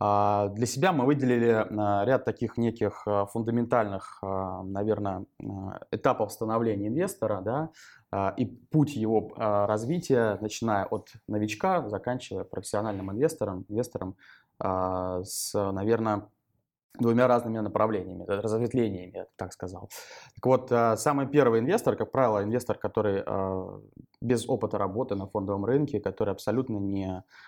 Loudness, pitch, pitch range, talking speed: -28 LUFS, 110 Hz, 100-120 Hz, 110 wpm